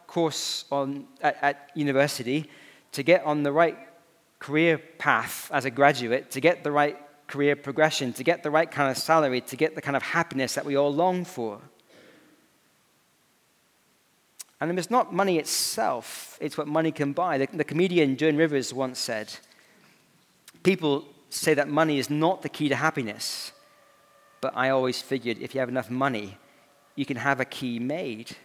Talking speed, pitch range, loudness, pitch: 175 wpm, 135-160 Hz, -26 LUFS, 145 Hz